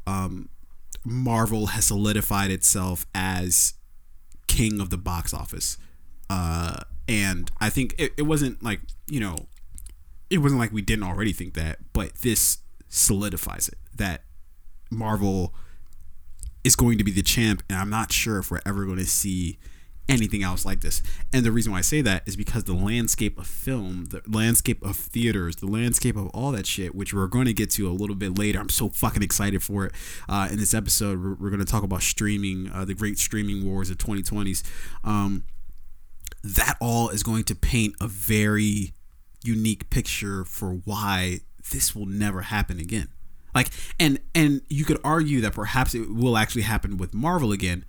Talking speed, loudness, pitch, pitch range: 180 wpm, -24 LUFS, 100 Hz, 90-110 Hz